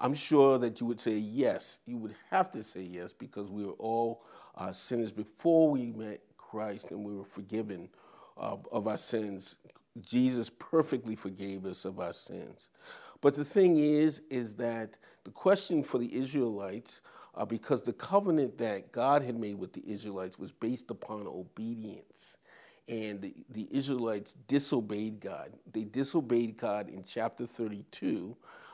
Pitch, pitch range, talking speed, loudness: 115 Hz, 105-135 Hz, 160 wpm, -33 LUFS